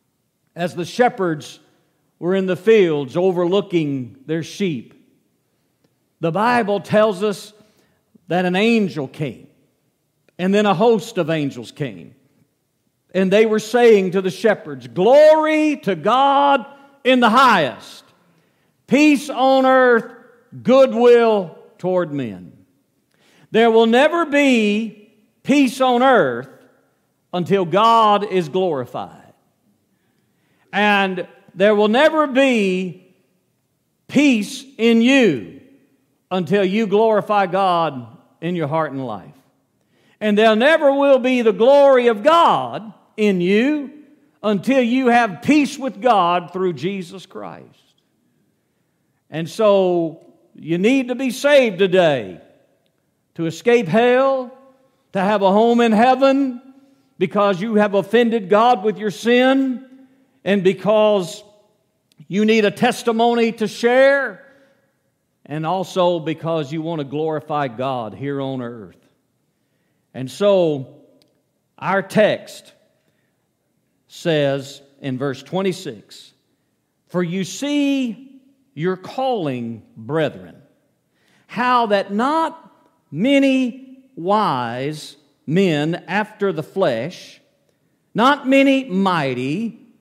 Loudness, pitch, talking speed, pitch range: -17 LUFS, 205 Hz, 110 wpm, 170-245 Hz